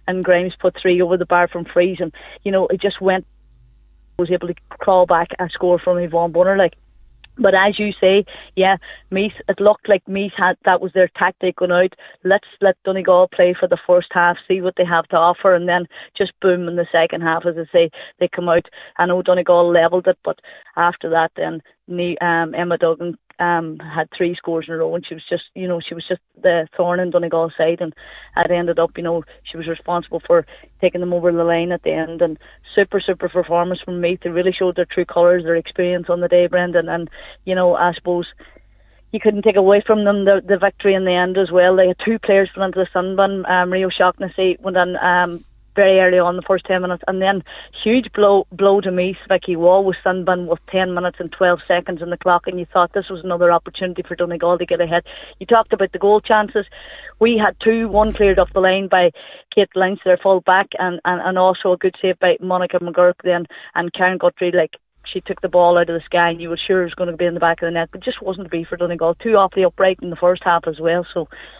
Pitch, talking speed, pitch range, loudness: 180 Hz, 245 wpm, 175-190 Hz, -17 LUFS